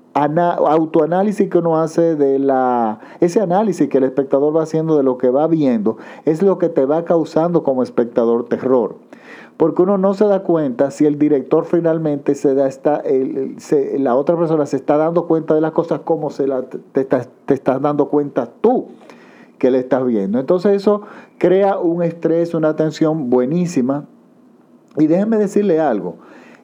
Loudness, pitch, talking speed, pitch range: -16 LUFS, 155 Hz, 180 wpm, 140-170 Hz